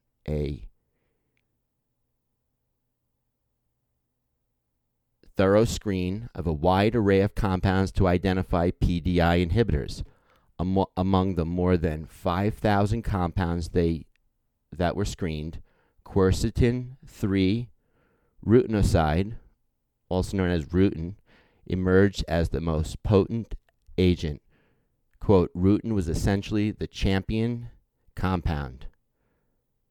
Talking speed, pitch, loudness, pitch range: 85 wpm, 95 Hz, -25 LUFS, 85-100 Hz